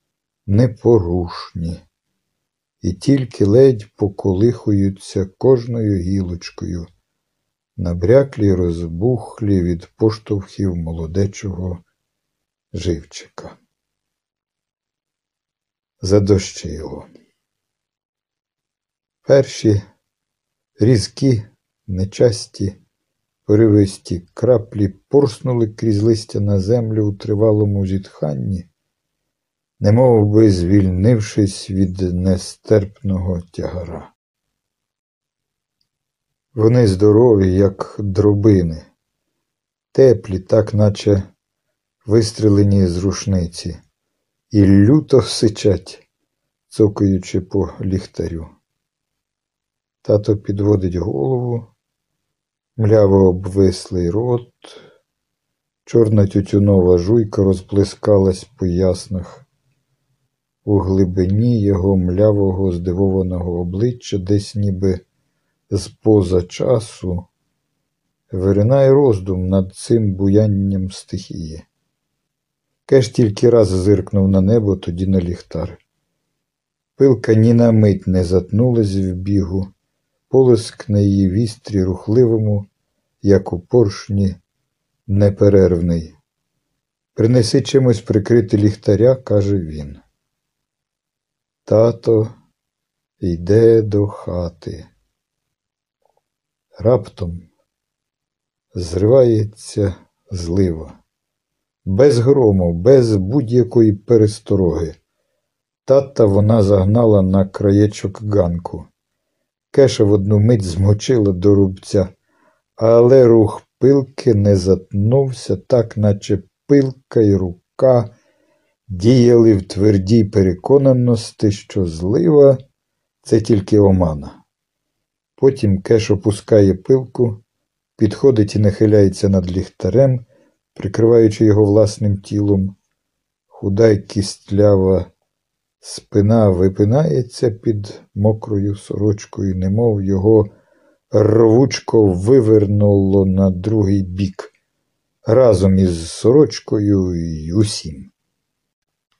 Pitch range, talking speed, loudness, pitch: 95-115 Hz, 75 wpm, -15 LUFS, 105 Hz